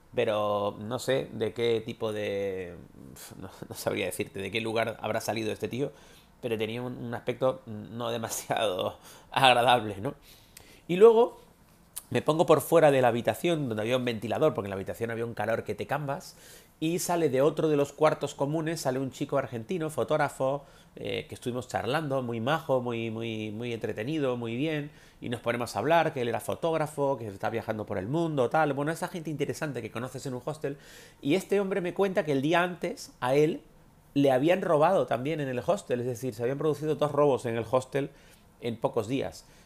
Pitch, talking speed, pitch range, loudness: 135 Hz, 195 wpm, 115-155 Hz, -29 LUFS